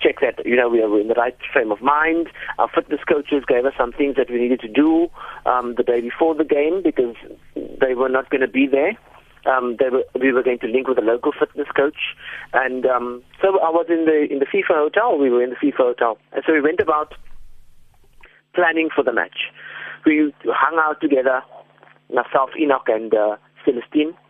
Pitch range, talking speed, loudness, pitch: 125-160 Hz, 210 wpm, -19 LUFS, 145 Hz